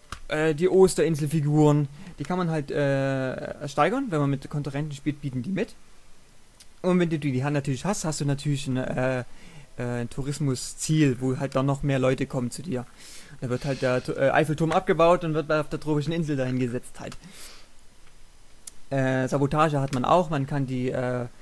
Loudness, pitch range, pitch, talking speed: -25 LUFS, 130-155 Hz, 145 Hz, 175 wpm